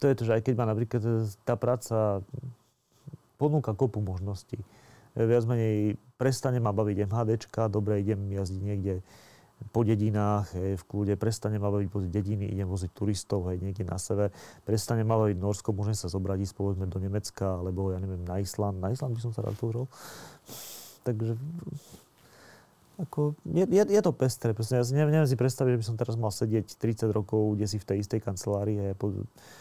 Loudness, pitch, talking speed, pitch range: -29 LUFS, 110 Hz, 190 wpm, 100-120 Hz